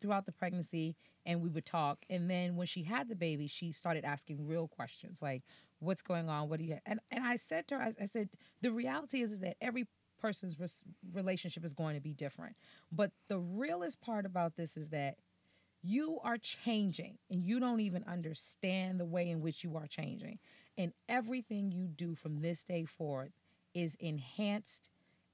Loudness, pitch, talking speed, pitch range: -40 LUFS, 180 Hz, 195 wpm, 160-210 Hz